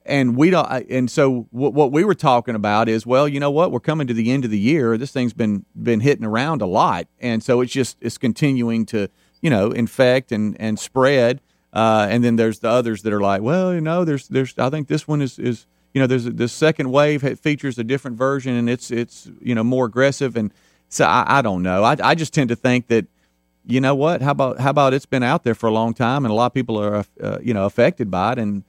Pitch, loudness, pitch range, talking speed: 125 Hz, -19 LUFS, 115-140 Hz, 255 wpm